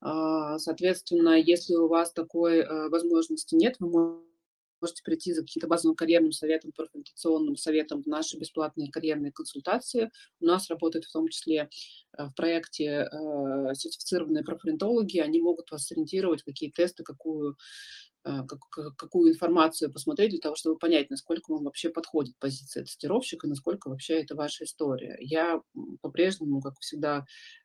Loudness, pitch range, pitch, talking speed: -29 LUFS, 150-170 Hz, 160 Hz, 135 wpm